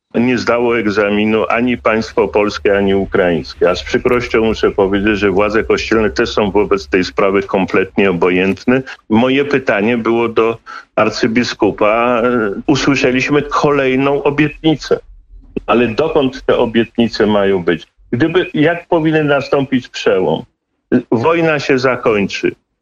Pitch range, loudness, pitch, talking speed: 110-145 Hz, -14 LUFS, 125 Hz, 120 wpm